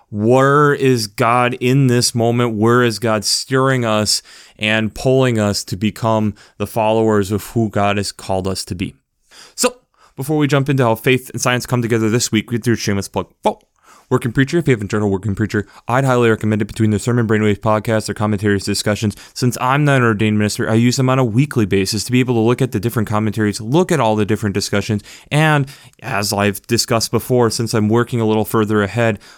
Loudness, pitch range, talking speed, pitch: -16 LUFS, 105-125 Hz, 215 wpm, 115 Hz